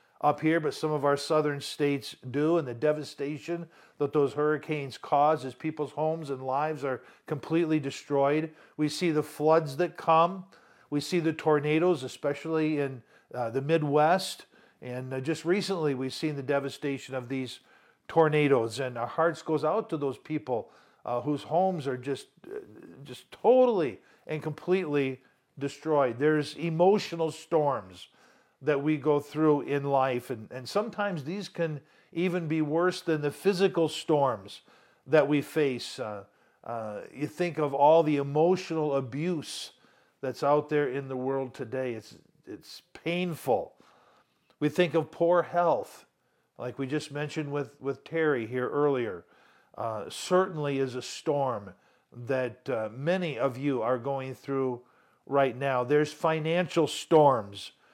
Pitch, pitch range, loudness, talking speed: 150 Hz, 135-160 Hz, -29 LUFS, 150 wpm